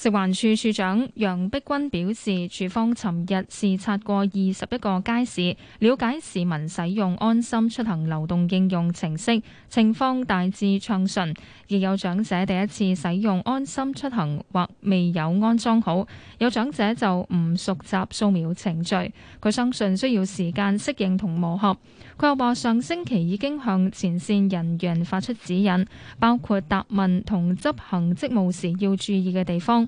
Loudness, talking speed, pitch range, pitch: -24 LUFS, 240 characters per minute, 185-230 Hz, 195 Hz